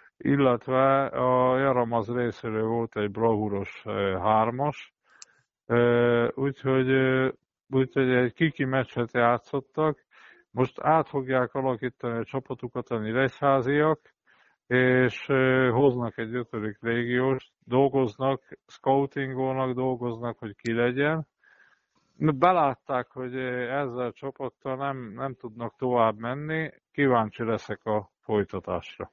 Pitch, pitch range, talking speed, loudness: 125 Hz, 120-135 Hz, 95 wpm, -26 LUFS